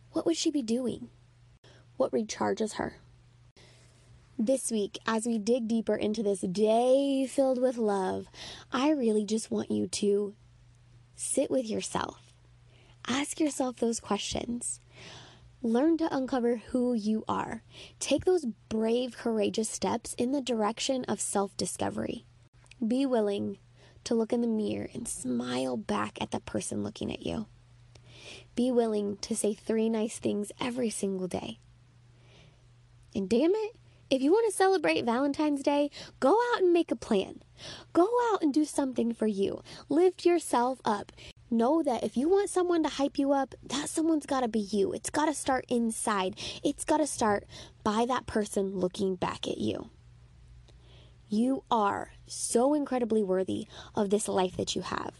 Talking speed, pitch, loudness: 160 wpm, 220 Hz, -30 LUFS